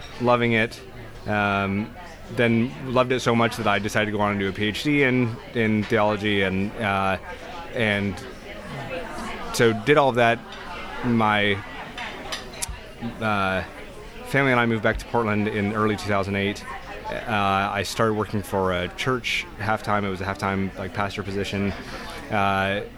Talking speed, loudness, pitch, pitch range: 155 wpm, -23 LUFS, 105 Hz, 100-115 Hz